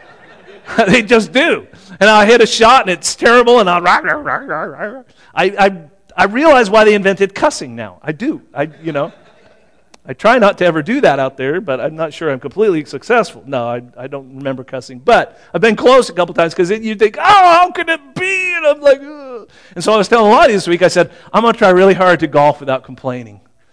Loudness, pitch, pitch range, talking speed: -12 LUFS, 195 Hz, 150-240 Hz, 225 wpm